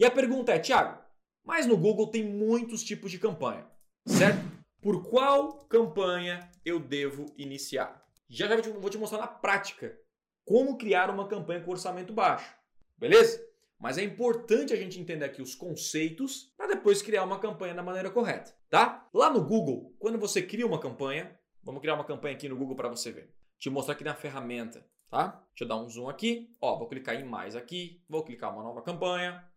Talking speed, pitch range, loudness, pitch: 195 wpm, 155-225 Hz, -30 LUFS, 195 Hz